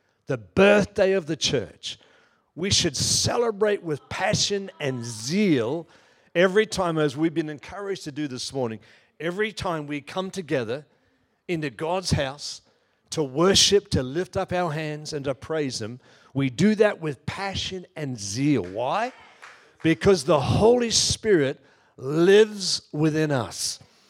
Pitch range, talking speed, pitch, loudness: 140-195 Hz, 140 wpm, 160 Hz, -24 LUFS